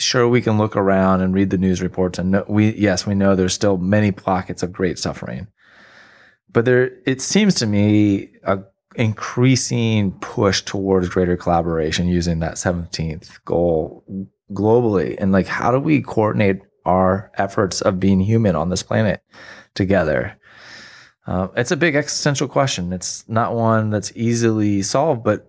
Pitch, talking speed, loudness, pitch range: 100 Hz, 160 wpm, -18 LUFS, 95-115 Hz